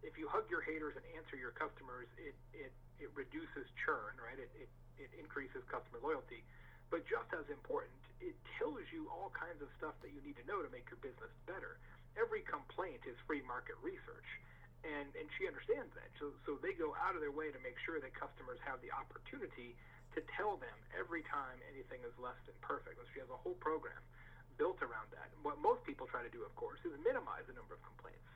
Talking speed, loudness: 220 wpm, -46 LUFS